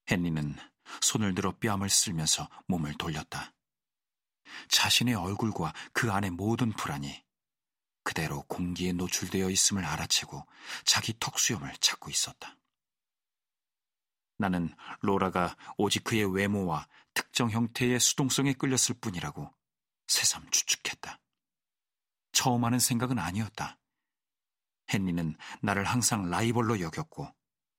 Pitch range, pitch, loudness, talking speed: 90-120 Hz, 100 Hz, -29 LUFS, 255 characters per minute